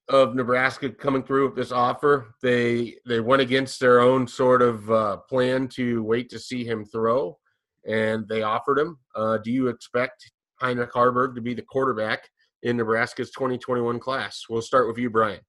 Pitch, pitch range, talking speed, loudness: 125 Hz, 115-130 Hz, 185 wpm, -23 LUFS